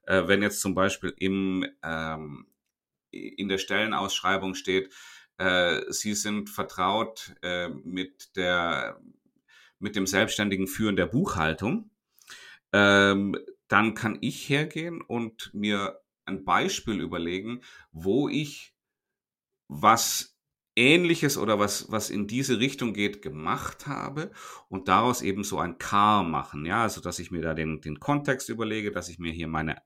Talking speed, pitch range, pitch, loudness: 140 wpm, 90-115 Hz, 100 Hz, -27 LUFS